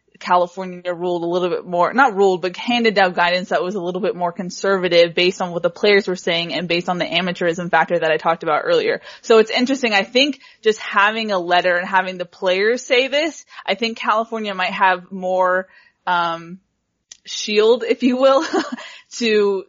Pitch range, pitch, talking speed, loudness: 180-225 Hz, 190 Hz, 195 wpm, -18 LUFS